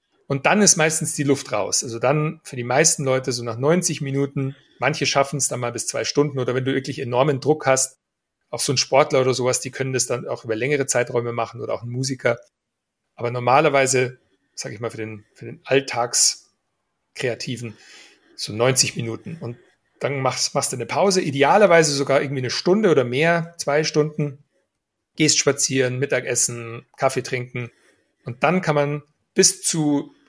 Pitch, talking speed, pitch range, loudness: 135 Hz, 180 wpm, 125-150 Hz, -20 LUFS